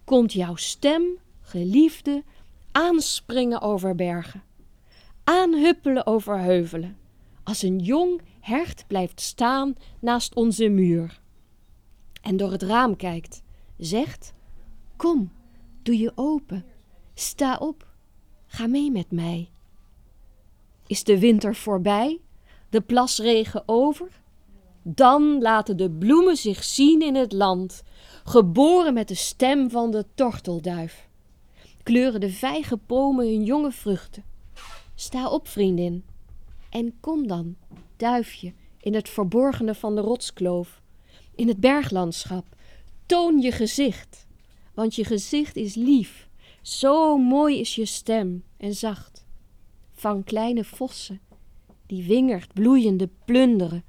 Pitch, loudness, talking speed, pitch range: 225 Hz, -22 LUFS, 115 wpm, 195-265 Hz